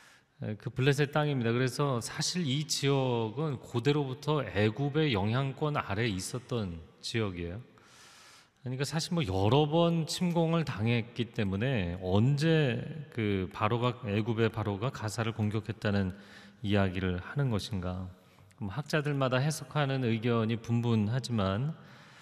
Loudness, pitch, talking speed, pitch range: -31 LUFS, 120 Hz, 285 characters per minute, 105-145 Hz